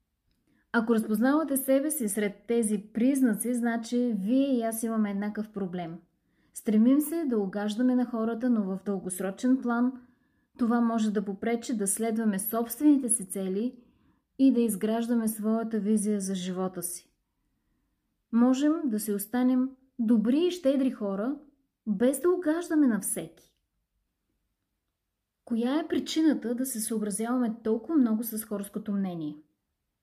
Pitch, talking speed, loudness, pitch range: 230 Hz, 130 wpm, -28 LUFS, 205-255 Hz